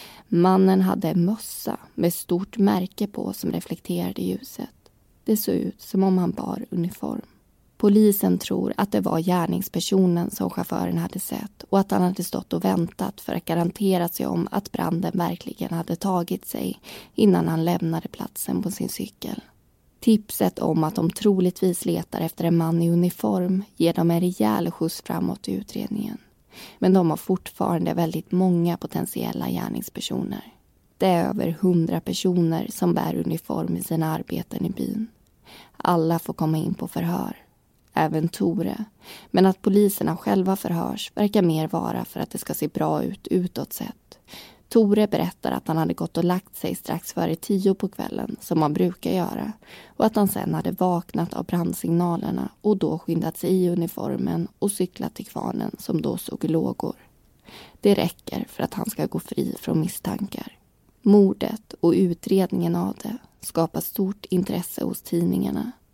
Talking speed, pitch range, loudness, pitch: 165 wpm, 170-200 Hz, -24 LUFS, 180 Hz